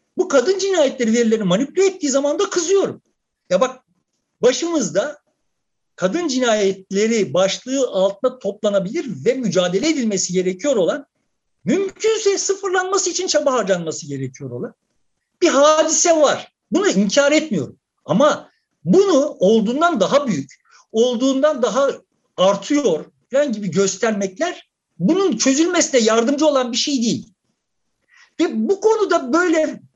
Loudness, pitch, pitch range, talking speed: -18 LUFS, 275 Hz, 215-335 Hz, 115 wpm